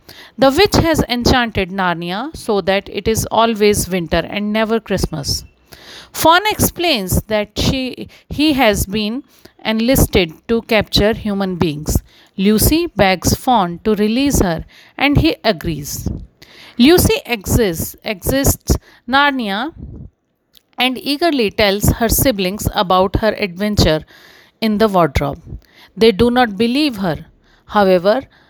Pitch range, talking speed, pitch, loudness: 185-245 Hz, 120 wpm, 215 Hz, -15 LUFS